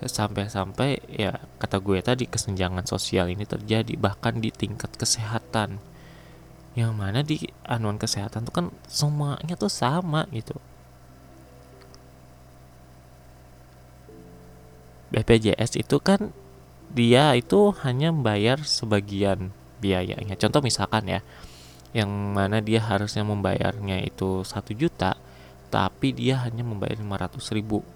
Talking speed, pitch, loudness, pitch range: 105 wpm, 105 Hz, -25 LUFS, 90-120 Hz